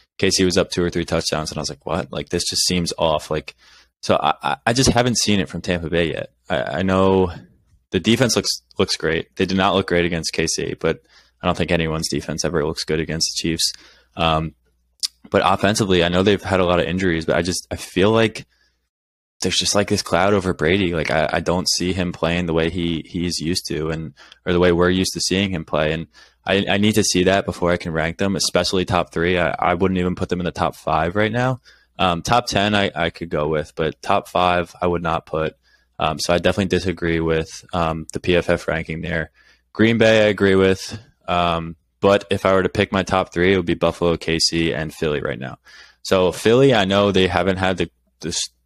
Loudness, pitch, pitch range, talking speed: -19 LUFS, 90 Hz, 80-95 Hz, 235 wpm